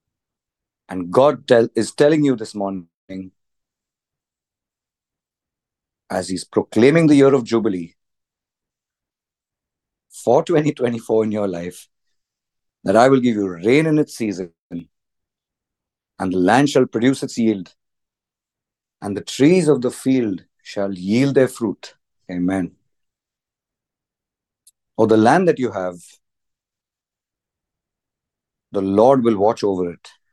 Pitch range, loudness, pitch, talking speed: 95-130 Hz, -17 LUFS, 110 Hz, 120 wpm